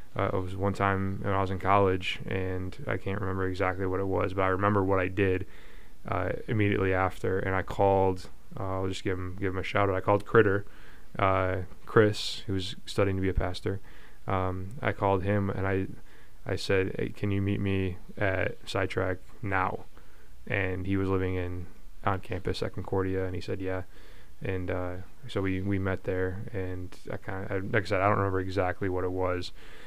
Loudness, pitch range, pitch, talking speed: -30 LUFS, 95-100 Hz, 95 Hz, 205 wpm